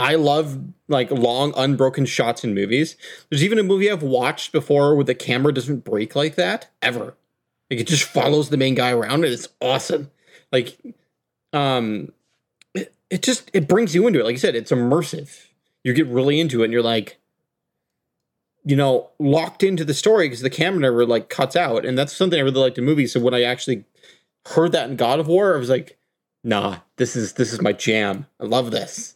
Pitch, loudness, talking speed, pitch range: 140 Hz, -20 LUFS, 210 wpm, 125-160 Hz